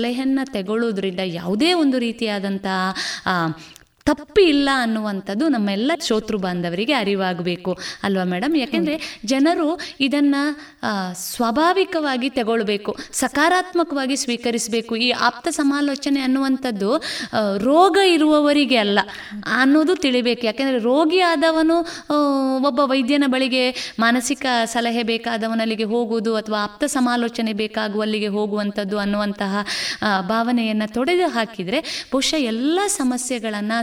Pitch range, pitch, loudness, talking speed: 215-290 Hz, 245 Hz, -20 LUFS, 95 wpm